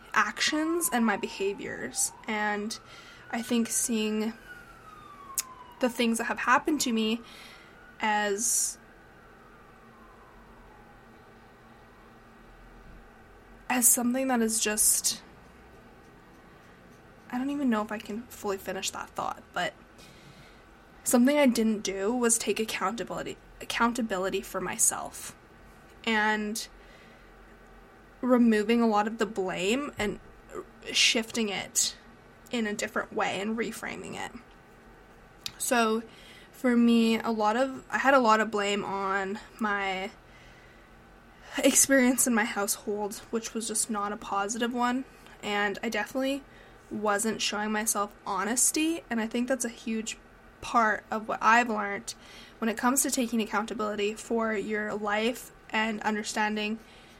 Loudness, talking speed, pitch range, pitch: -28 LUFS, 120 wpm, 210-245 Hz, 220 Hz